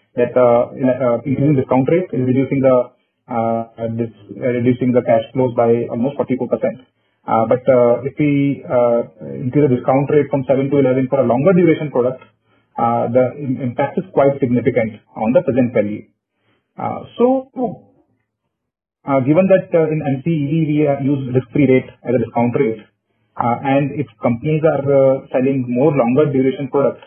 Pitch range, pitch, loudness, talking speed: 120-140 Hz, 130 Hz, -16 LUFS, 170 wpm